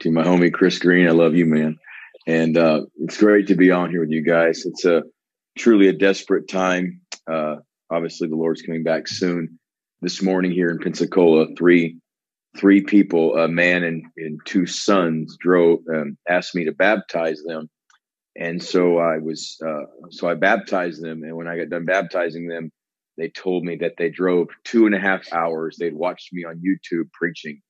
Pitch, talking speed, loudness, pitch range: 85 Hz, 190 wpm, -19 LUFS, 80-90 Hz